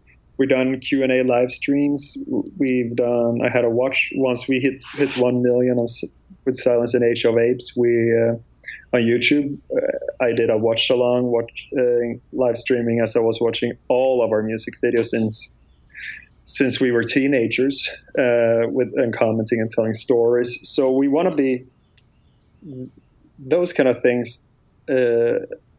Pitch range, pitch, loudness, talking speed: 115-135 Hz, 125 Hz, -20 LUFS, 160 wpm